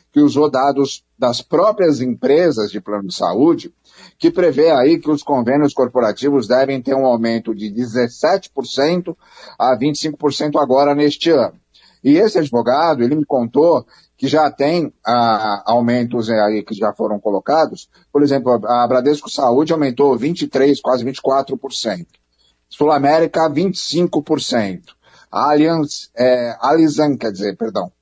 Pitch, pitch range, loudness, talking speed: 135 Hz, 120-150 Hz, -16 LUFS, 135 wpm